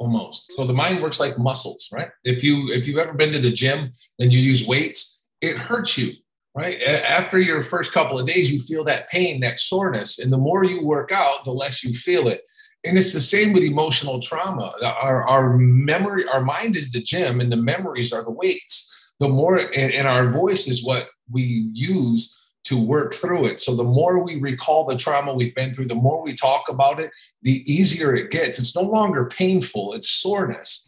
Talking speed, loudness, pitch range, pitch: 215 wpm, -20 LUFS, 125-175 Hz, 140 Hz